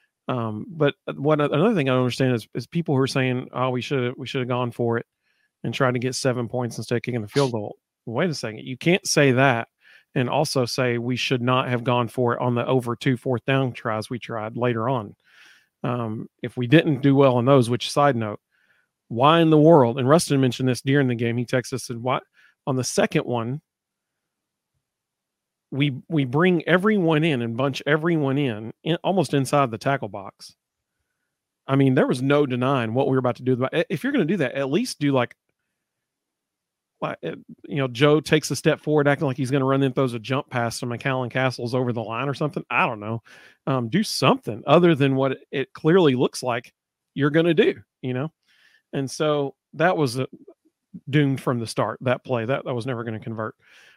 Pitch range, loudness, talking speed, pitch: 125-145 Hz, -22 LUFS, 220 wpm, 130 Hz